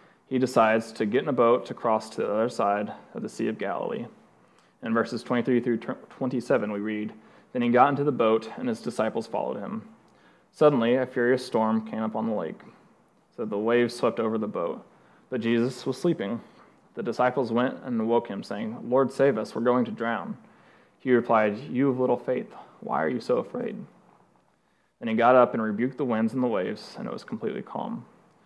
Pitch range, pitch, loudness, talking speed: 110-130 Hz, 120 Hz, -26 LUFS, 205 wpm